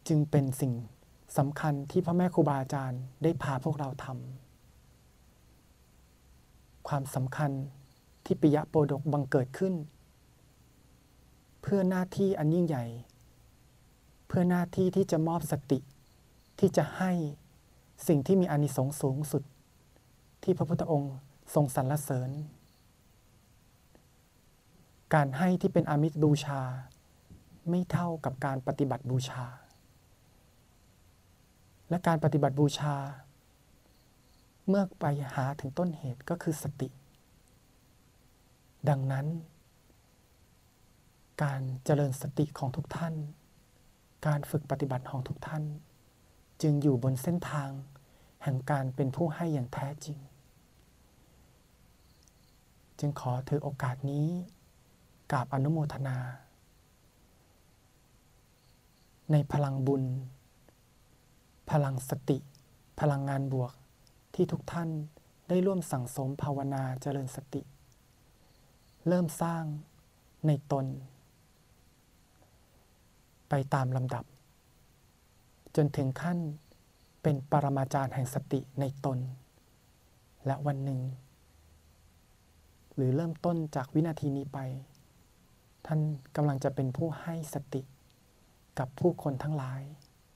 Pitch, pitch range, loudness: 140 Hz, 130-155 Hz, -32 LUFS